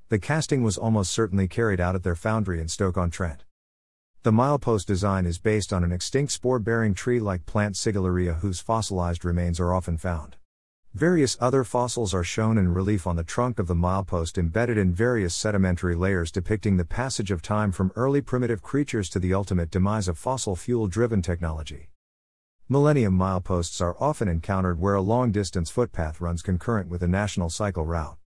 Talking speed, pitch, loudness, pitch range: 185 wpm, 95 Hz, -25 LUFS, 90-115 Hz